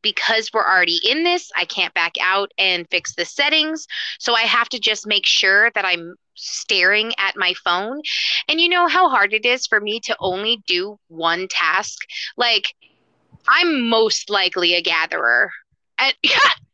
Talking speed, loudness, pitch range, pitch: 170 wpm, -17 LUFS, 190-295 Hz, 220 Hz